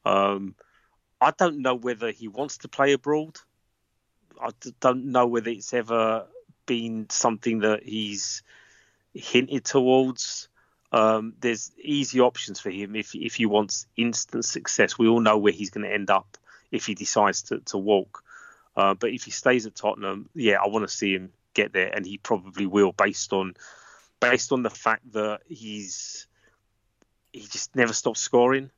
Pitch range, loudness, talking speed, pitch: 105-125 Hz, -25 LUFS, 170 wpm, 110 Hz